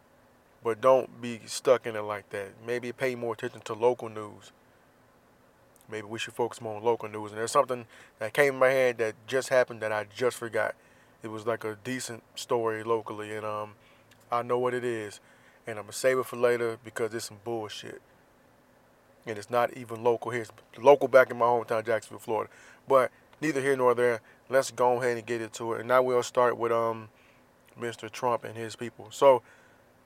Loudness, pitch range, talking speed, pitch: -28 LUFS, 110-125 Hz, 200 wpm, 115 Hz